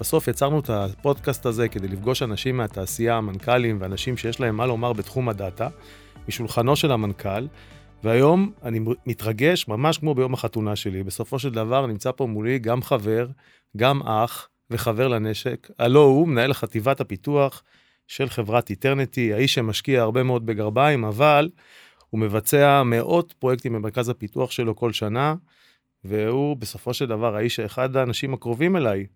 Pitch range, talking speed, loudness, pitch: 110-135 Hz, 150 wpm, -23 LUFS, 120 Hz